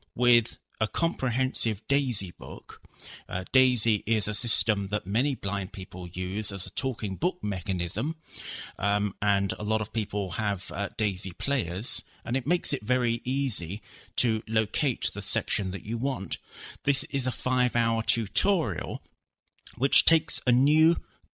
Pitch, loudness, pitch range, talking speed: 110 Hz, -26 LUFS, 100-130 Hz, 150 wpm